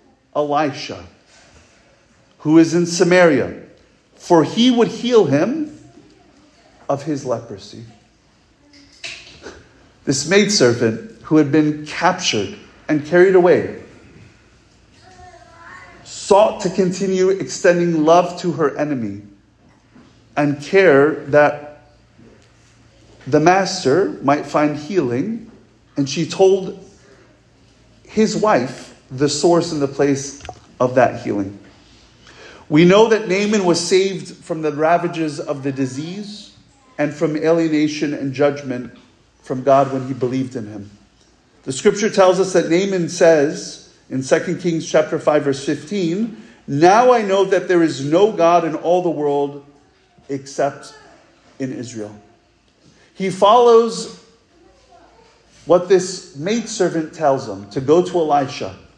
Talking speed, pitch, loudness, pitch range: 115 wpm, 155 Hz, -17 LUFS, 135-185 Hz